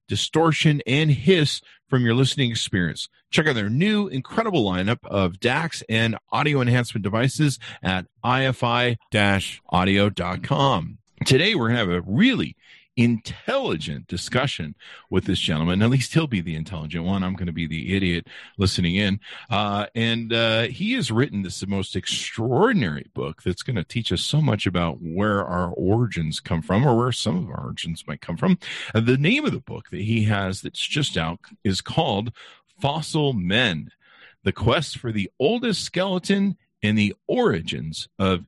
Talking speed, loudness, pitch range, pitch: 170 wpm, -23 LUFS, 95-135 Hz, 115 Hz